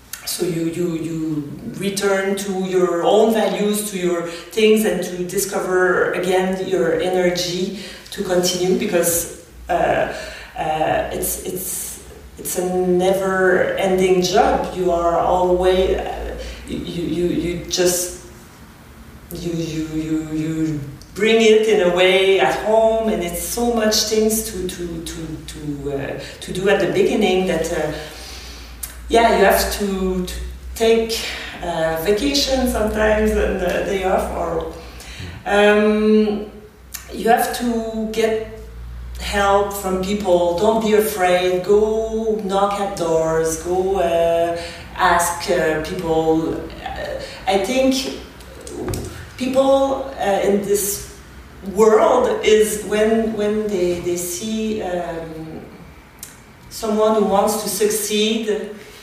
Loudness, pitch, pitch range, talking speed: -18 LUFS, 185 Hz, 170-210 Hz, 120 wpm